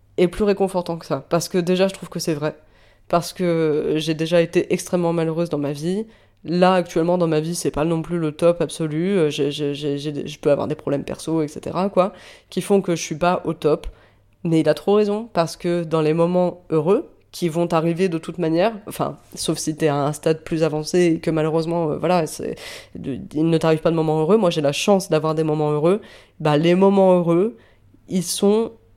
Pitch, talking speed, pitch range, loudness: 165 Hz, 215 wpm, 155-180 Hz, -20 LUFS